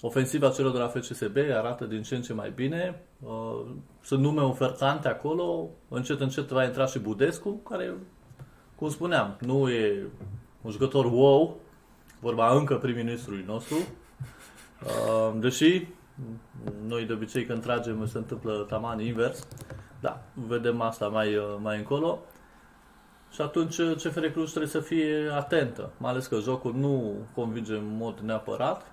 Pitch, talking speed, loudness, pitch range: 125 Hz, 140 wpm, -28 LUFS, 115-140 Hz